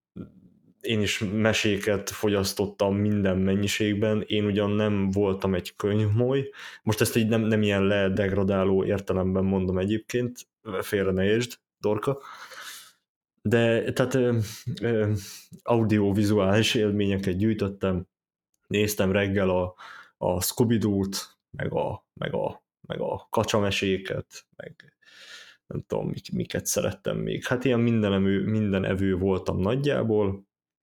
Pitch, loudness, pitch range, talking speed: 105 Hz, -26 LUFS, 95-110 Hz, 120 wpm